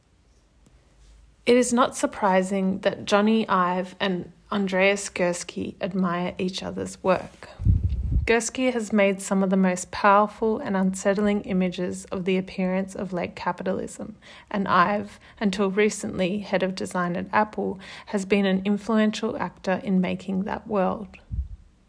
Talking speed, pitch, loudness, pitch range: 135 wpm, 190 Hz, -24 LUFS, 180-205 Hz